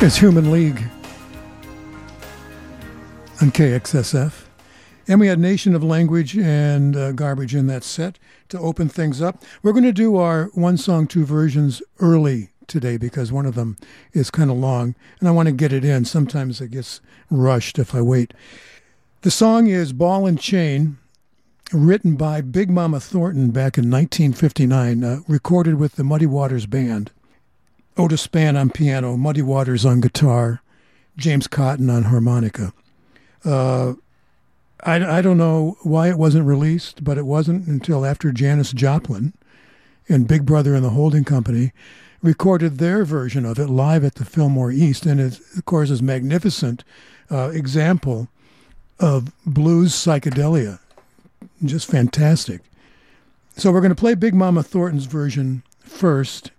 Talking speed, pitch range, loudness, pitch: 155 wpm, 130-165 Hz, -18 LUFS, 145 Hz